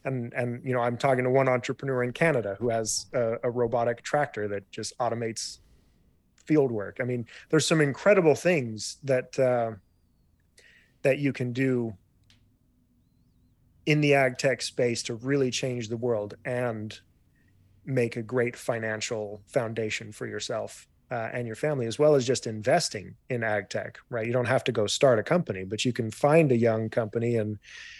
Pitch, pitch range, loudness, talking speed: 120 Hz, 110-130 Hz, -27 LUFS, 175 wpm